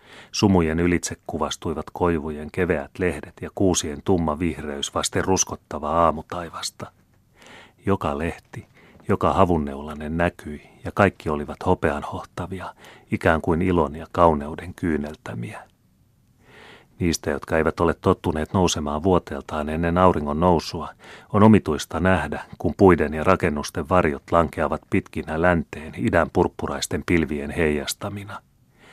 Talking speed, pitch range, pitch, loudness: 110 wpm, 75-90 Hz, 85 Hz, -23 LUFS